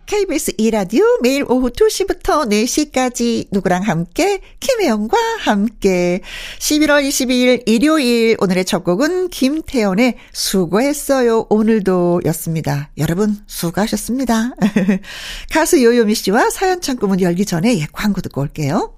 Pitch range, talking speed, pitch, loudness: 195-290 Hz, 285 characters per minute, 225 Hz, -16 LUFS